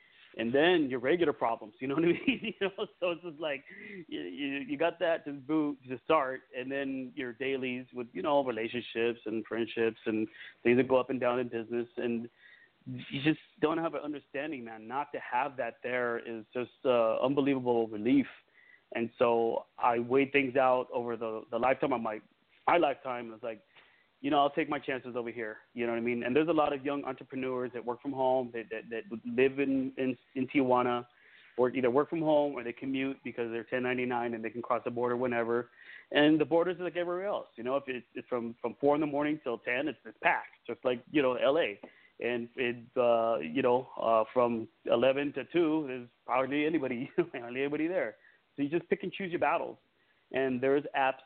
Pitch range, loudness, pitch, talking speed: 120-145 Hz, -32 LUFS, 130 Hz, 215 wpm